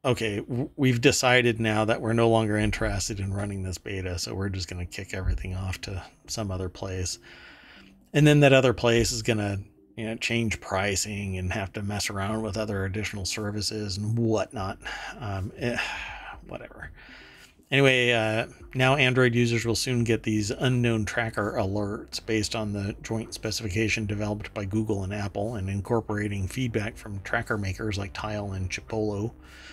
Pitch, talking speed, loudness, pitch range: 110 Hz, 165 wpm, -27 LUFS, 100-115 Hz